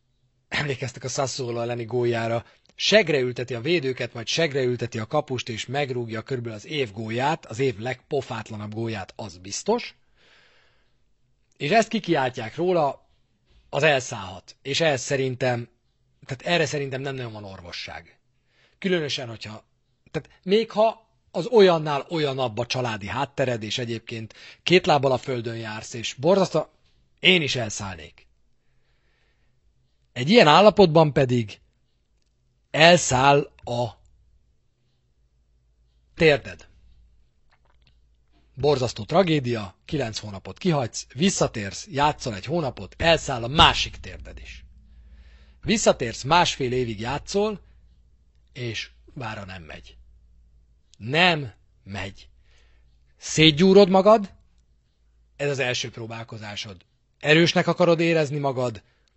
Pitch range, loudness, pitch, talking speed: 100-145 Hz, -22 LUFS, 125 Hz, 105 wpm